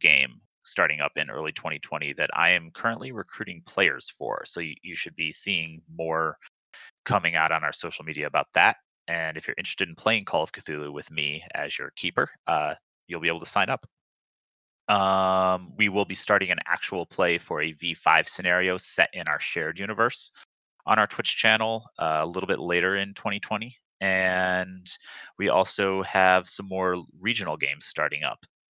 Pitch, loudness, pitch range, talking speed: 95 Hz, -25 LUFS, 85-95 Hz, 180 wpm